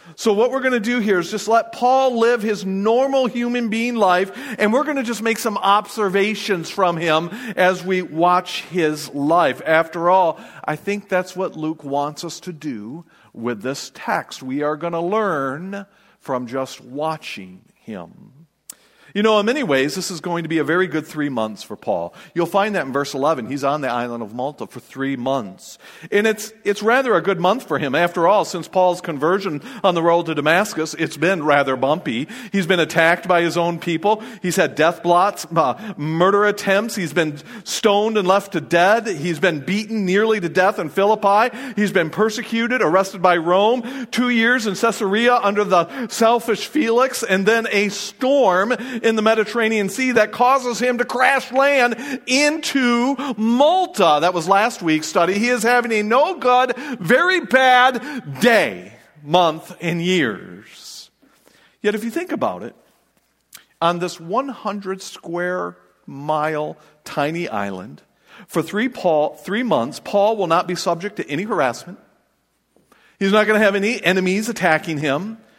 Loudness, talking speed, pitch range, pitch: -19 LUFS, 170 wpm, 170-230 Hz, 195 Hz